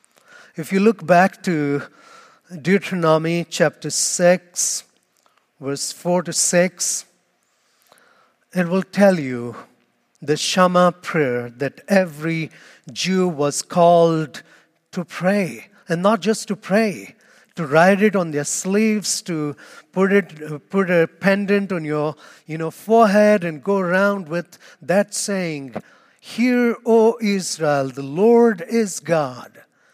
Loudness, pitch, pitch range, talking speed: -19 LUFS, 180 Hz, 160-205 Hz, 120 wpm